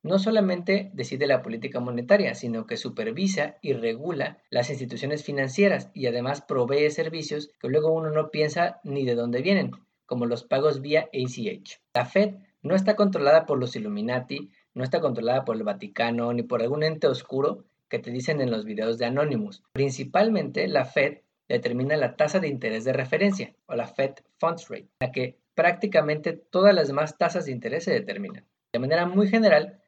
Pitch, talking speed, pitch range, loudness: 150 Hz, 180 wpm, 125-190 Hz, -25 LUFS